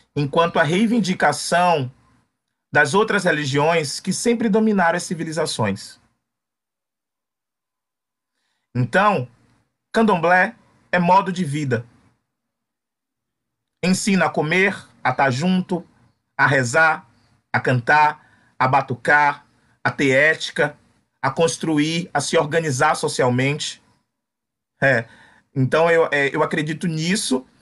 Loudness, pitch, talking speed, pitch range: -19 LUFS, 155 Hz, 100 wpm, 130-175 Hz